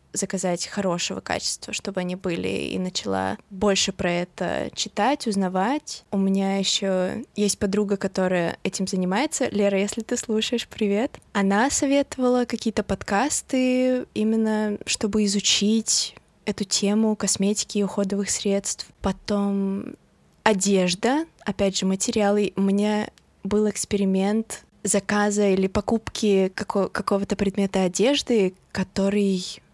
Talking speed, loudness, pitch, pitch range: 115 wpm, -23 LUFS, 205 Hz, 195-220 Hz